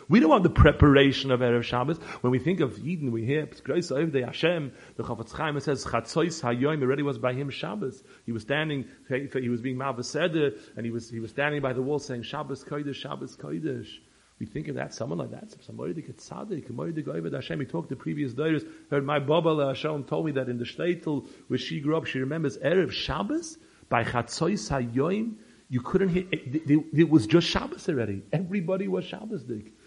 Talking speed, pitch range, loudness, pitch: 190 wpm, 125-160 Hz, -27 LUFS, 140 Hz